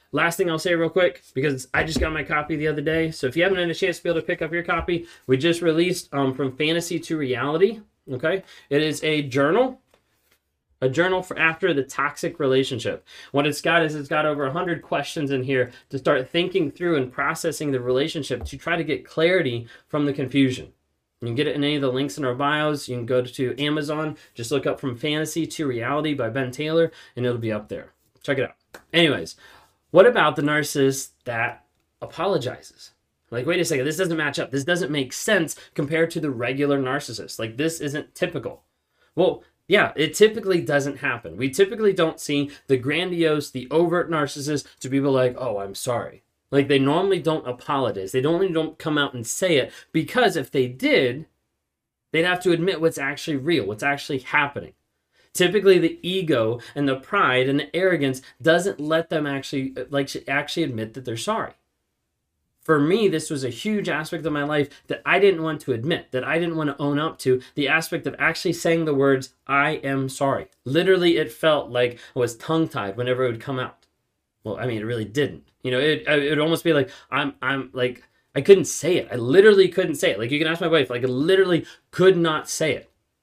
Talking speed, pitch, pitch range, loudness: 210 wpm, 145 Hz, 130-165 Hz, -22 LUFS